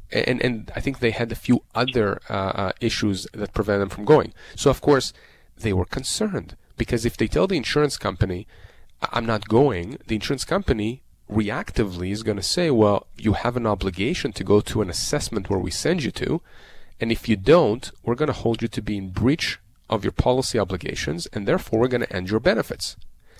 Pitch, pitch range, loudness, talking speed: 110 Hz, 100-125 Hz, -23 LUFS, 205 wpm